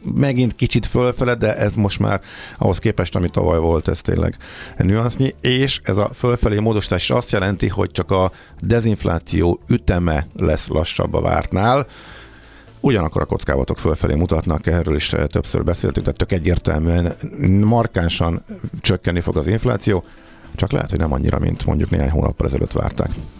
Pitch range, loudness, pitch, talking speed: 85-115 Hz, -19 LUFS, 95 Hz, 150 wpm